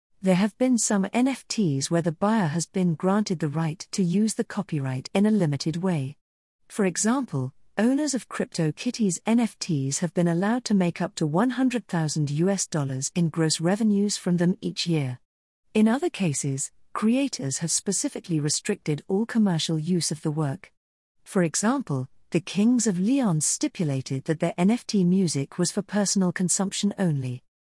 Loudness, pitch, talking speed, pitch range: -25 LUFS, 180 Hz, 160 wpm, 155-210 Hz